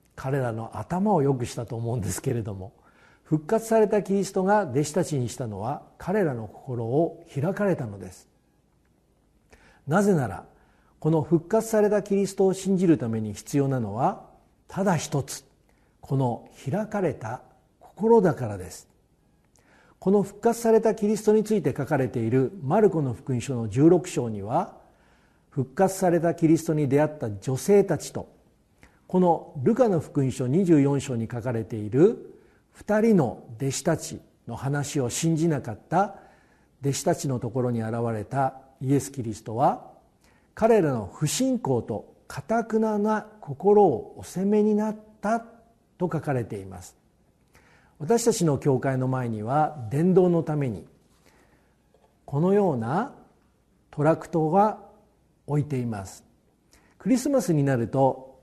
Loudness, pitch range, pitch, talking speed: -25 LUFS, 125-195 Hz, 150 Hz, 275 characters per minute